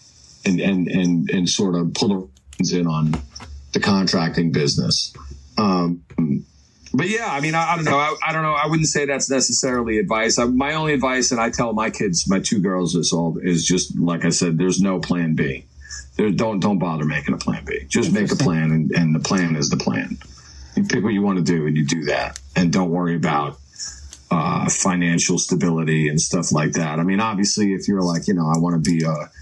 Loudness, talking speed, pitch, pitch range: -20 LUFS, 220 wpm, 85 Hz, 80-110 Hz